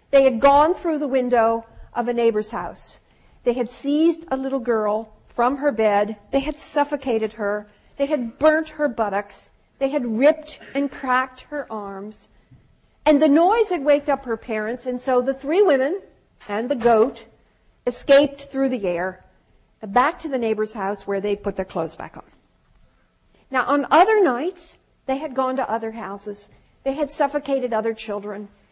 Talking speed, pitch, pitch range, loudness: 170 wpm, 255 Hz, 220-290 Hz, -21 LUFS